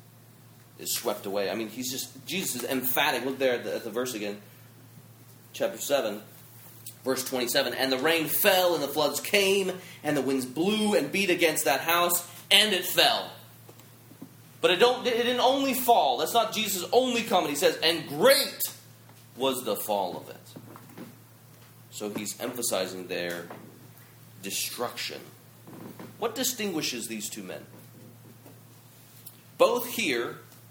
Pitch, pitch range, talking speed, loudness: 130 Hz, 120-170 Hz, 145 wpm, -26 LUFS